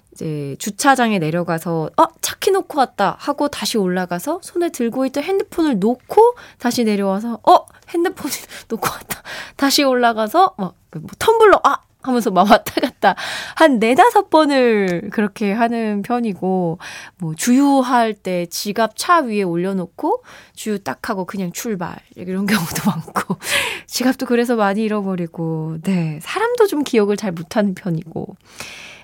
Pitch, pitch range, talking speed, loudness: 220 Hz, 185-275 Hz, 295 characters per minute, -18 LUFS